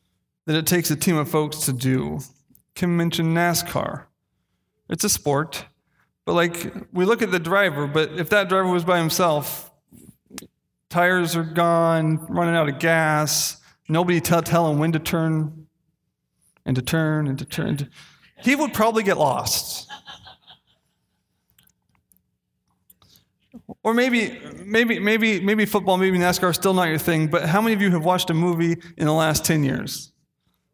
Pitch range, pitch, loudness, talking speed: 155-185 Hz, 170 Hz, -21 LUFS, 160 wpm